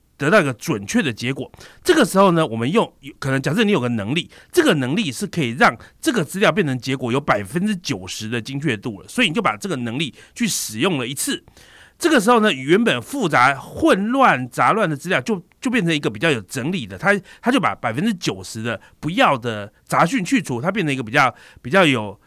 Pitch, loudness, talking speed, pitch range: 160 Hz, -19 LUFS, 330 characters per minute, 130-210 Hz